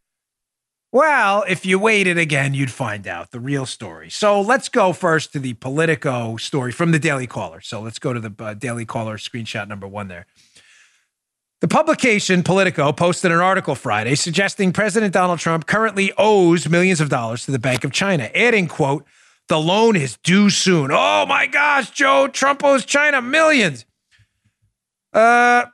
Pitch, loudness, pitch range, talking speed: 165 Hz, -17 LUFS, 125-200 Hz, 170 wpm